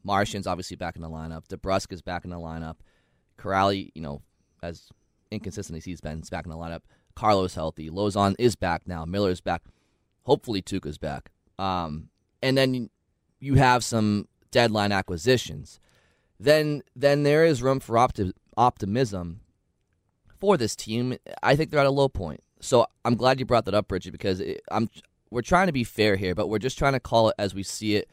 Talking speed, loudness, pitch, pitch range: 190 wpm, -25 LUFS, 100 Hz, 90-120 Hz